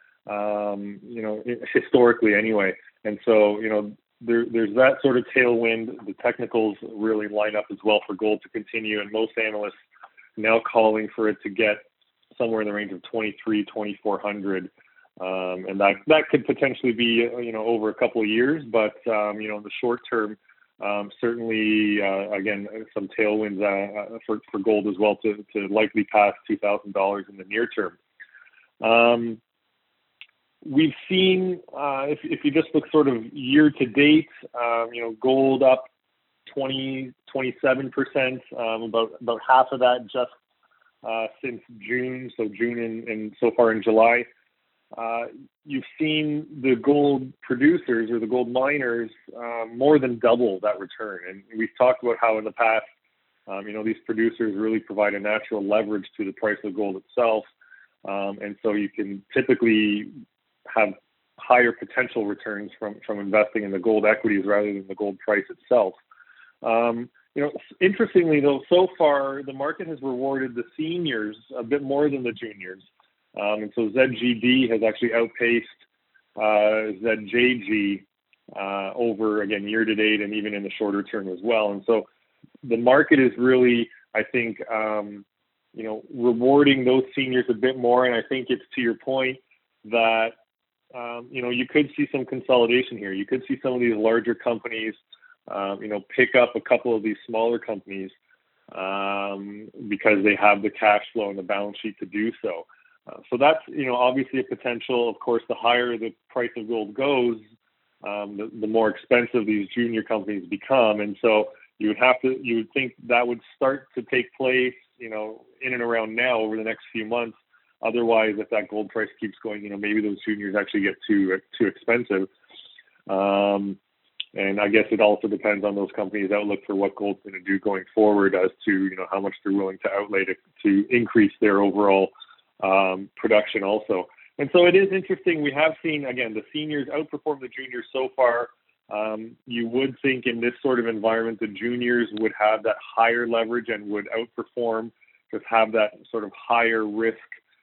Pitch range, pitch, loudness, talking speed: 105-125 Hz, 115 Hz, -23 LUFS, 180 wpm